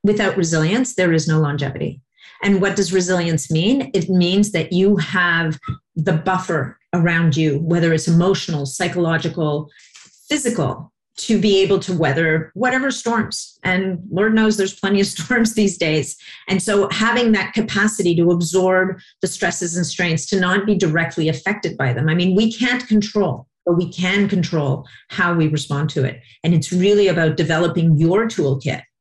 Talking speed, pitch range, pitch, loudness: 165 wpm, 160-200 Hz, 180 Hz, -18 LUFS